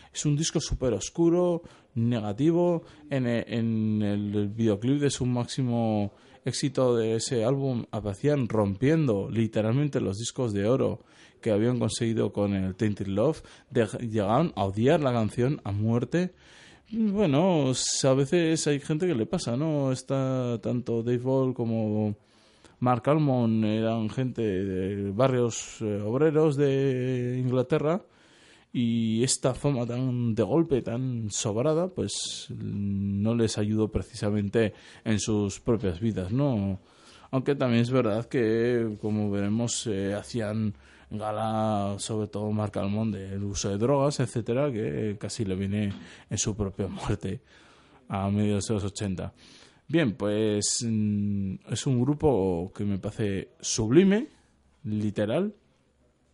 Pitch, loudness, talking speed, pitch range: 115 Hz, -27 LUFS, 130 wpm, 105-130 Hz